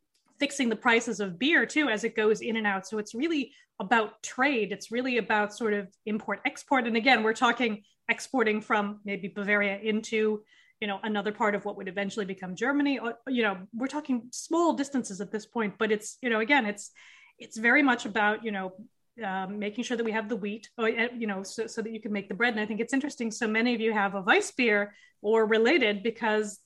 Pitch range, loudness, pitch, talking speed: 210-240 Hz, -28 LUFS, 225 Hz, 225 wpm